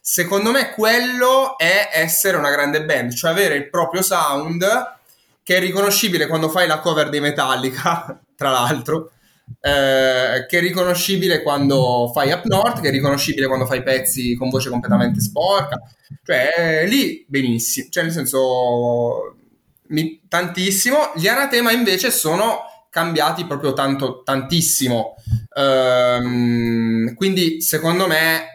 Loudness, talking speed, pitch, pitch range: -17 LUFS, 130 wpm, 155 Hz, 130-180 Hz